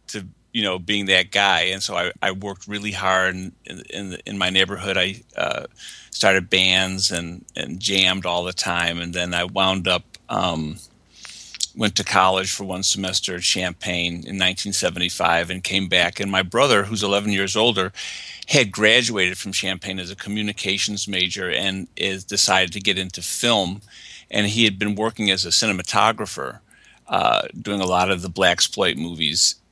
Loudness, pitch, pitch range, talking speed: -20 LUFS, 95 Hz, 90-100 Hz, 170 wpm